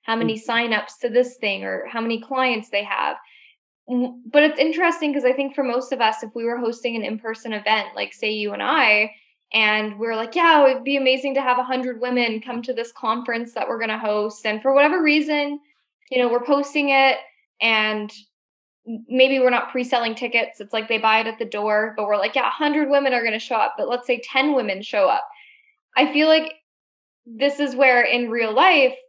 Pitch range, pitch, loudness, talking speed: 220-275 Hz, 245 Hz, -20 LUFS, 220 wpm